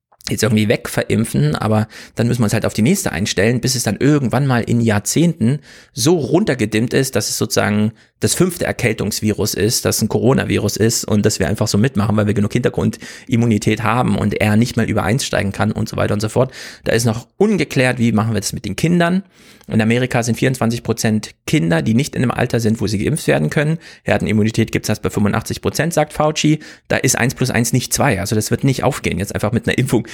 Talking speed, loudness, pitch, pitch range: 225 wpm, -17 LUFS, 115 Hz, 105-130 Hz